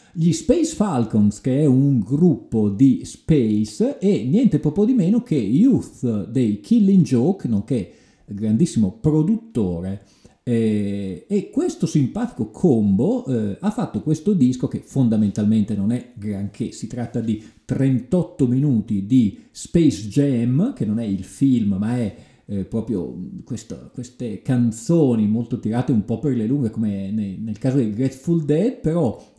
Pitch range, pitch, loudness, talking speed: 110-165 Hz, 125 Hz, -20 LUFS, 140 wpm